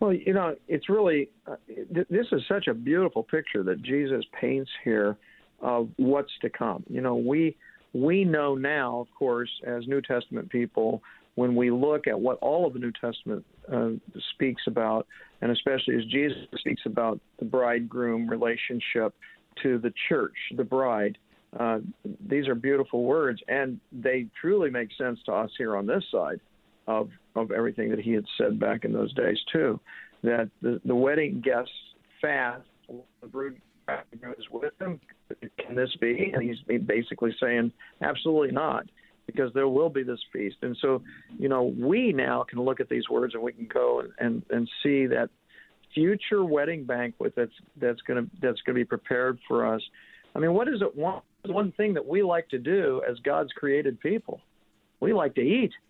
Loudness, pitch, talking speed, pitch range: -28 LUFS, 130 Hz, 180 wpm, 120-145 Hz